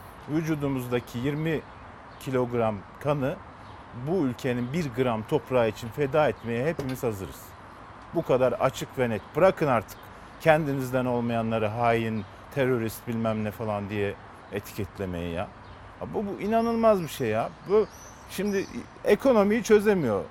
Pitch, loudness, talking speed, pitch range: 125 Hz, -27 LUFS, 120 wpm, 110-150 Hz